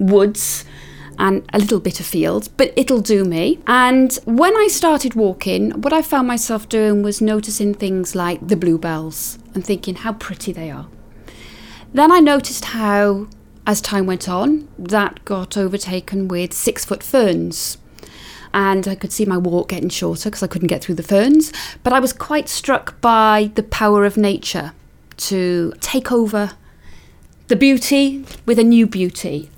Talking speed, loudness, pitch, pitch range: 165 wpm, -17 LUFS, 205 Hz, 180-240 Hz